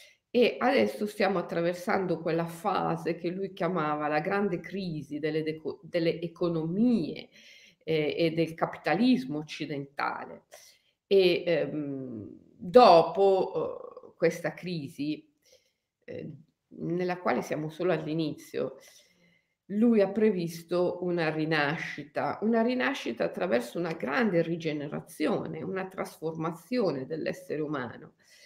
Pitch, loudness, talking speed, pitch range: 175 Hz, -29 LUFS, 100 wpm, 160-200 Hz